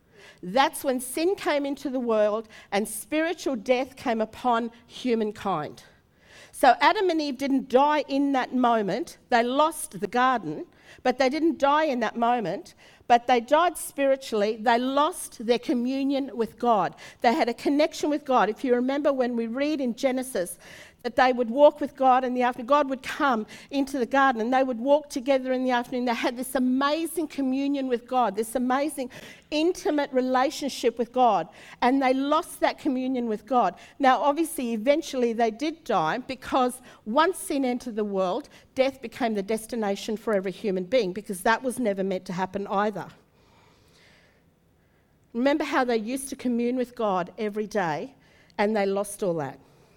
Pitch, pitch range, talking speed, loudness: 255 Hz, 230-280 Hz, 170 wpm, -25 LUFS